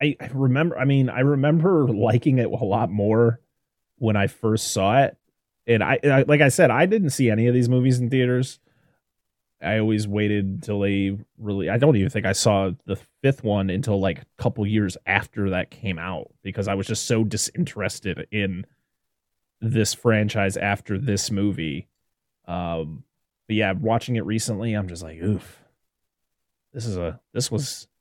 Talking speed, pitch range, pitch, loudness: 175 wpm, 100-125 Hz, 110 Hz, -22 LUFS